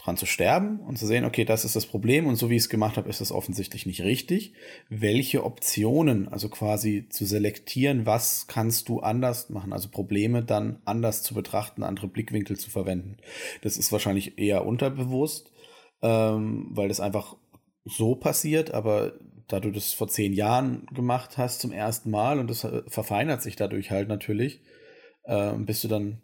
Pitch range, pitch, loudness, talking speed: 105-125 Hz, 110 Hz, -27 LUFS, 180 wpm